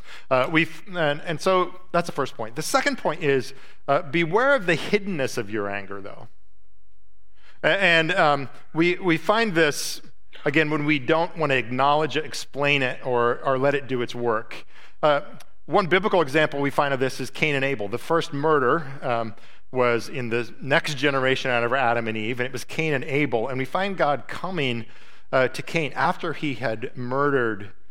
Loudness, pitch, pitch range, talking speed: -23 LUFS, 140 Hz, 125-160 Hz, 195 wpm